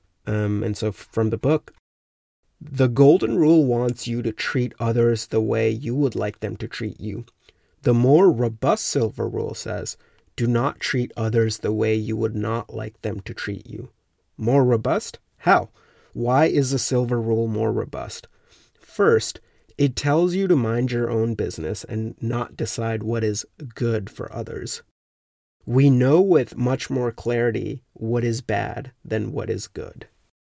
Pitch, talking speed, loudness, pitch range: 115 Hz, 165 wpm, -22 LUFS, 110-125 Hz